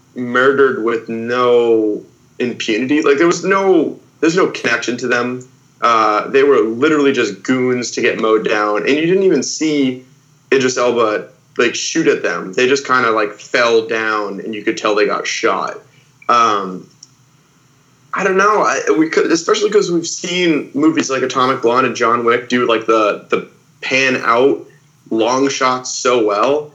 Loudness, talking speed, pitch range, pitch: -15 LUFS, 170 wpm, 120-160 Hz, 130 Hz